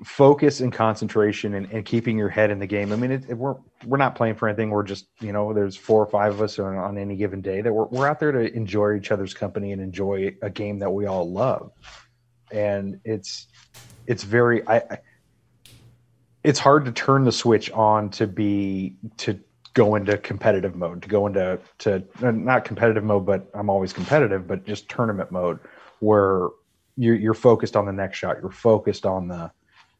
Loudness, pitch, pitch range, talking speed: -22 LUFS, 105 Hz, 100-120 Hz, 200 wpm